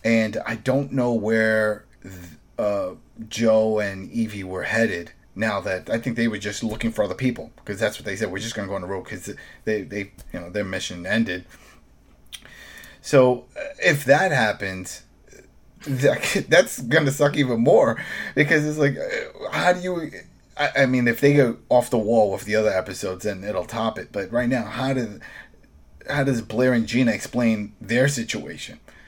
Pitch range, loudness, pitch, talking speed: 105-135 Hz, -22 LUFS, 115 Hz, 185 wpm